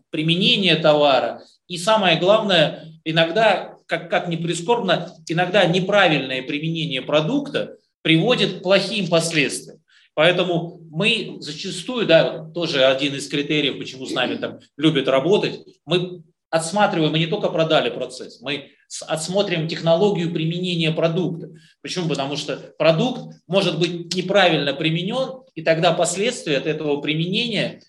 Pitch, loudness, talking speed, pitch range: 170 Hz, -20 LUFS, 125 wpm, 155-185 Hz